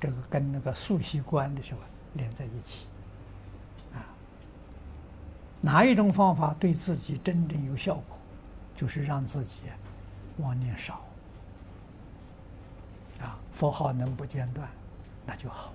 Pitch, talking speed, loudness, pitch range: 120 Hz, 180 characters per minute, -29 LUFS, 95-145 Hz